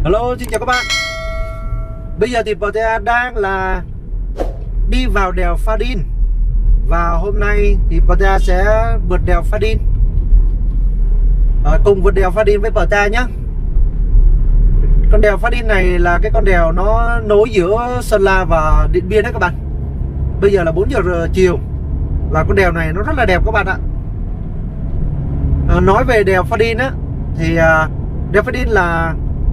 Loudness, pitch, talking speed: -15 LUFS, 165 Hz, 170 wpm